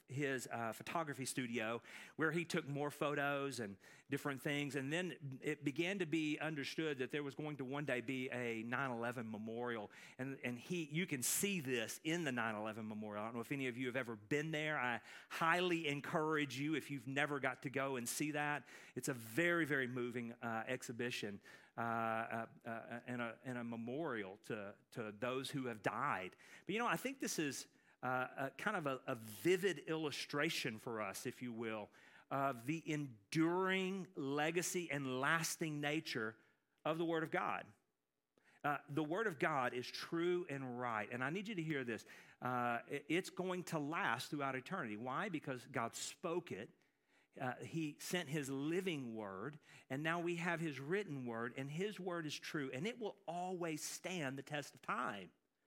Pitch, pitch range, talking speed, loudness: 140 Hz, 125-160 Hz, 190 wpm, -42 LUFS